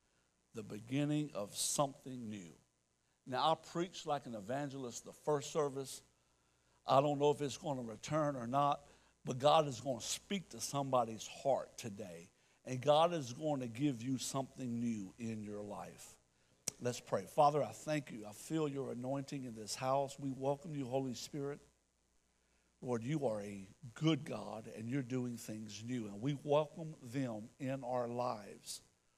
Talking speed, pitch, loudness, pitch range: 170 wpm, 130 Hz, -39 LUFS, 110-145 Hz